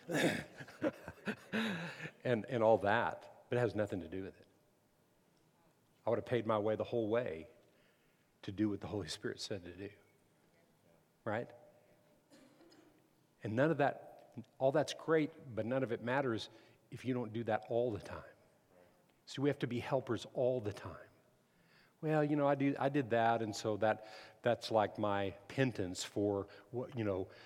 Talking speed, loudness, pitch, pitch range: 175 wpm, -37 LUFS, 115 Hz, 105-125 Hz